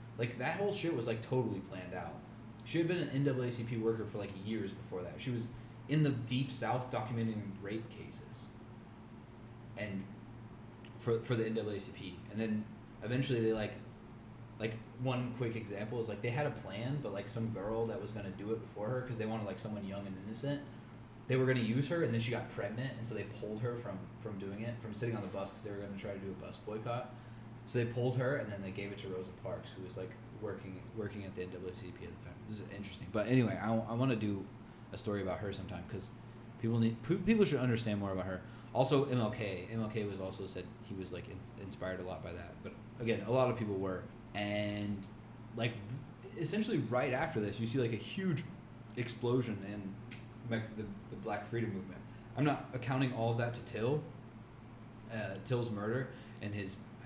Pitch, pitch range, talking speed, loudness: 115 Hz, 105-120 Hz, 215 wpm, -38 LUFS